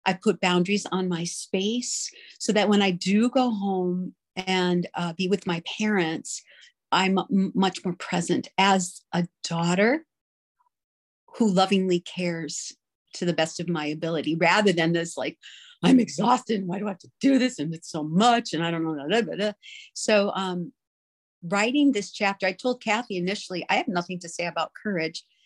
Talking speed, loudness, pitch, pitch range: 180 wpm, -25 LUFS, 185 Hz, 175-210 Hz